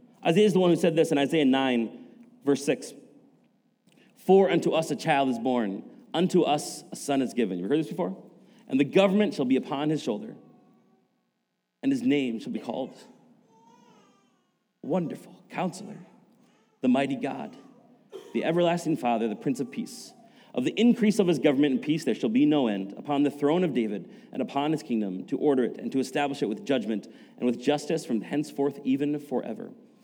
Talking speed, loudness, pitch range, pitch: 185 wpm, -26 LUFS, 140-210 Hz, 155 Hz